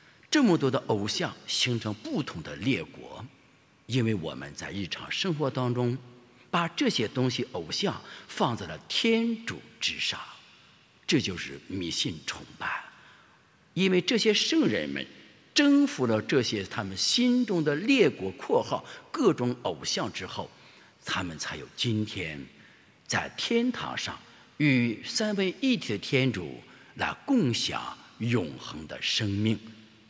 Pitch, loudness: 130 Hz, -28 LUFS